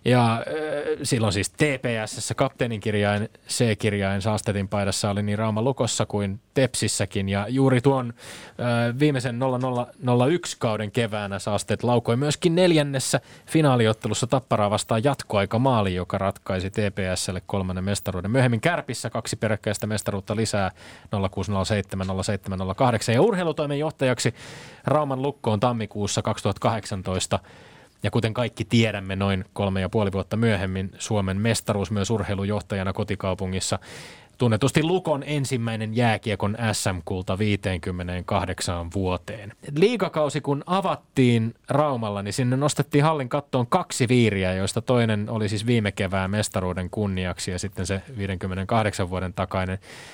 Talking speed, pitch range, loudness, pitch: 120 wpm, 100-130 Hz, -24 LUFS, 110 Hz